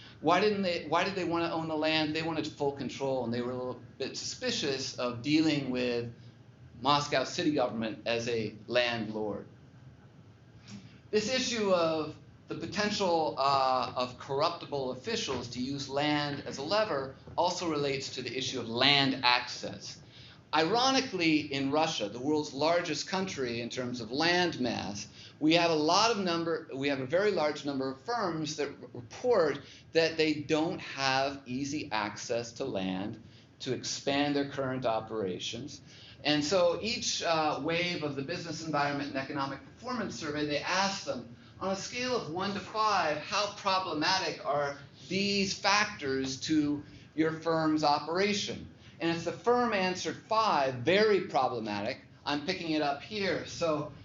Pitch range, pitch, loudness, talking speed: 130-170 Hz, 145 Hz, -31 LUFS, 155 wpm